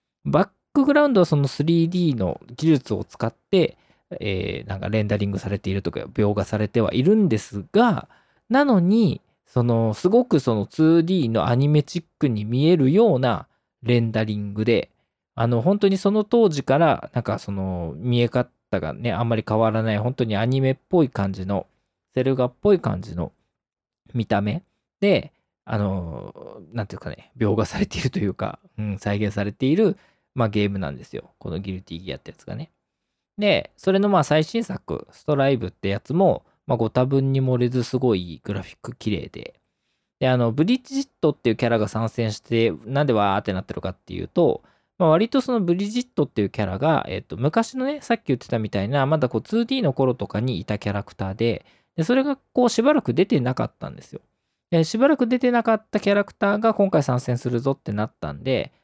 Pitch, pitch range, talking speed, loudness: 125 Hz, 105-180 Hz, 380 characters per minute, -22 LUFS